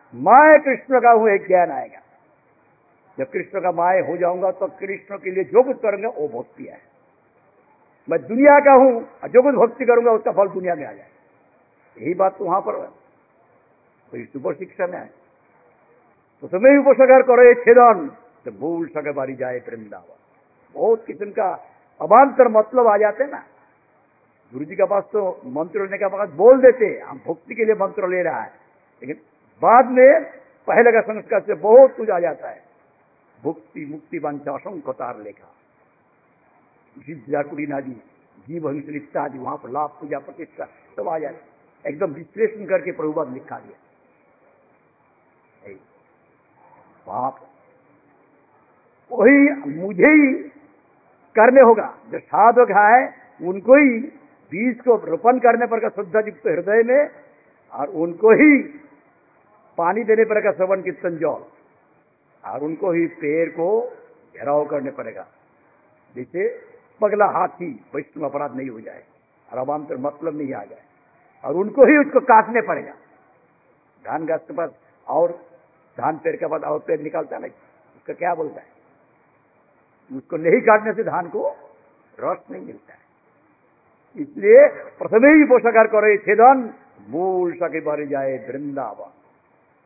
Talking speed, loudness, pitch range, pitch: 145 wpm, -17 LUFS, 170-260 Hz, 215 Hz